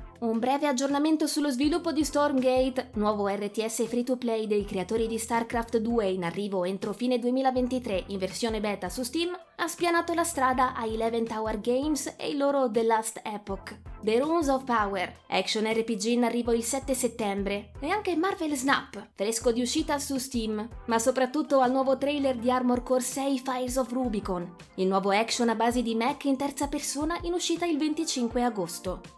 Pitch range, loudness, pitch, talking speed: 220-275 Hz, -28 LUFS, 245 Hz, 175 wpm